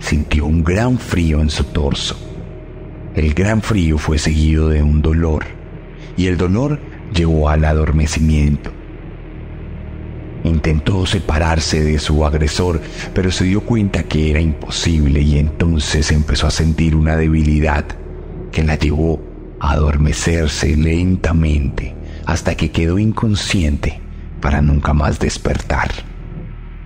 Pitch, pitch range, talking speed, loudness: 80 Hz, 75-85 Hz, 120 wpm, -16 LUFS